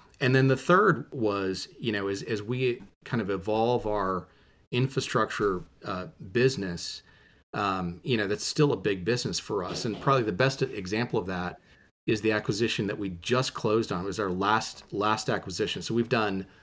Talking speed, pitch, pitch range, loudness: 185 wpm, 110 Hz, 100-125 Hz, -28 LUFS